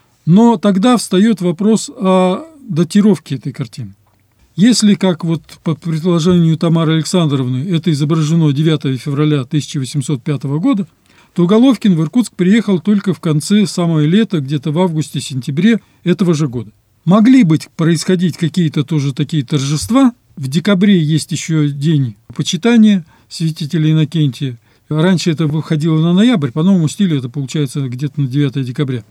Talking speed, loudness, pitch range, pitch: 135 wpm, -14 LUFS, 145-185 Hz, 160 Hz